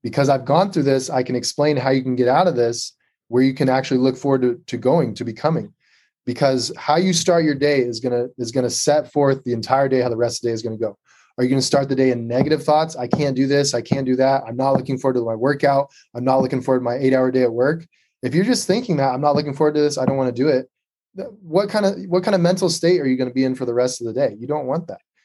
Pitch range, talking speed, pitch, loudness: 125-150 Hz, 295 wpm, 135 Hz, -19 LUFS